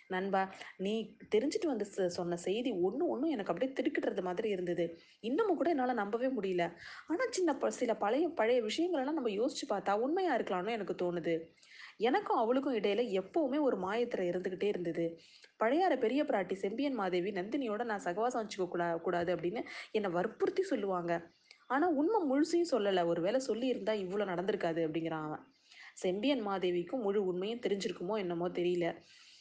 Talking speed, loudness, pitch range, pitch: 150 wpm, -34 LUFS, 180-270 Hz, 210 Hz